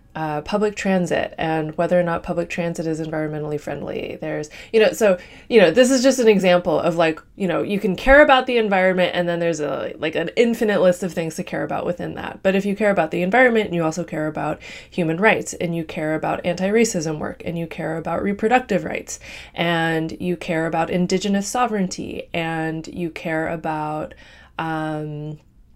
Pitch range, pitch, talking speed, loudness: 160-200 Hz, 170 Hz, 195 wpm, -20 LUFS